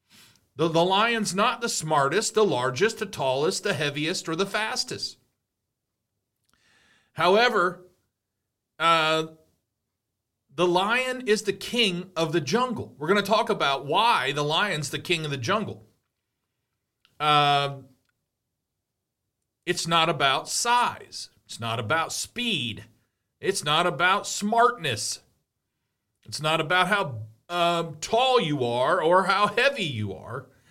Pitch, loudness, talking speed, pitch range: 165 Hz, -24 LUFS, 125 wpm, 125-200 Hz